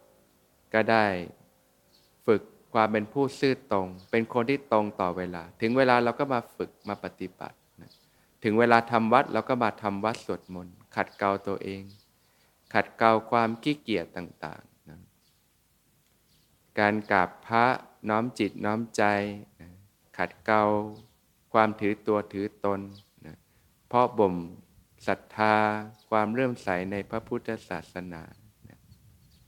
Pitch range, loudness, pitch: 95-115 Hz, -27 LUFS, 105 Hz